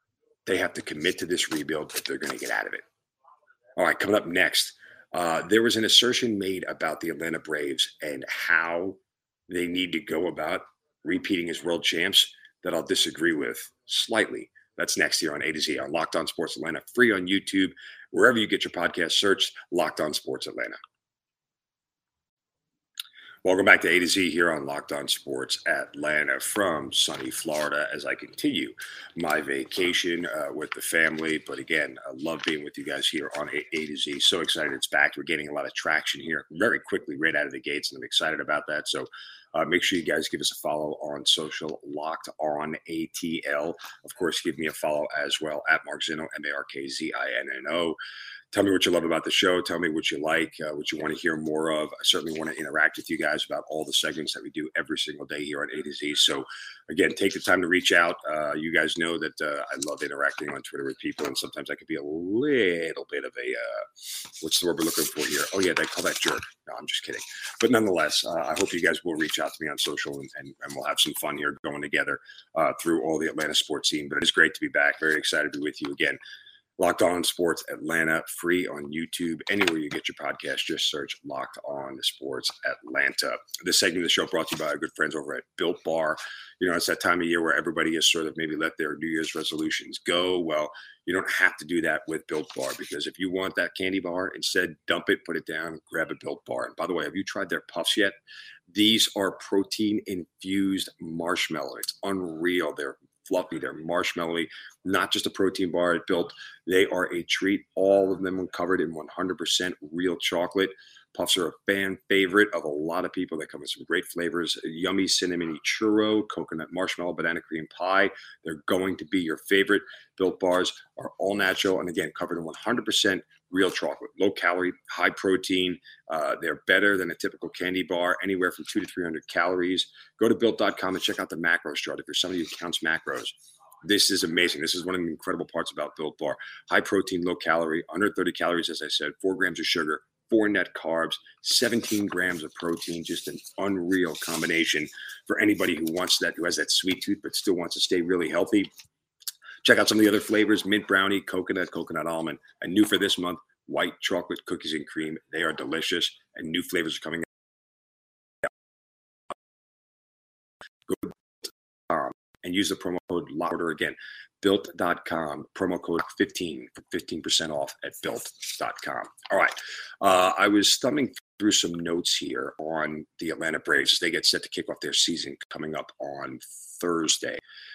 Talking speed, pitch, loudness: 215 wpm, 95 Hz, -26 LUFS